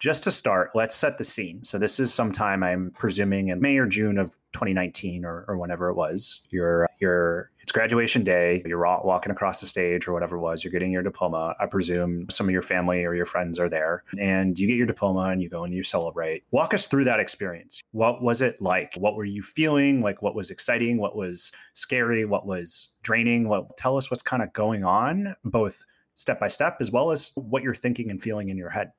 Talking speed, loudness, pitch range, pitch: 230 wpm, -25 LUFS, 90-115 Hz, 100 Hz